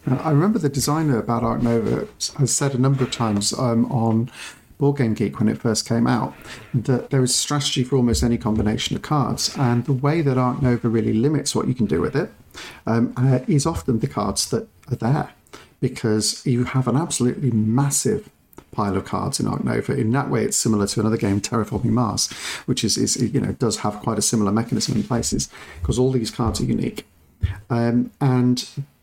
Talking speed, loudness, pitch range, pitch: 205 wpm, -21 LUFS, 115-130 Hz, 120 Hz